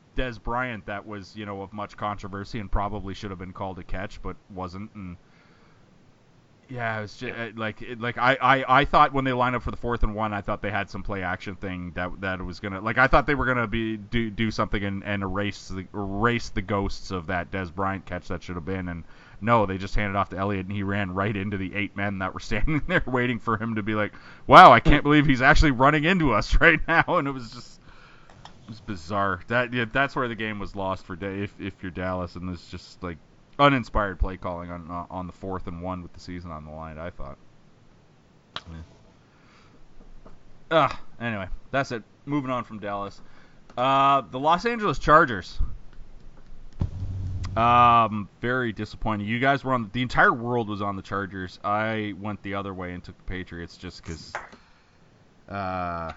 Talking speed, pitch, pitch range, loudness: 210 wpm, 105 Hz, 95-120 Hz, -24 LUFS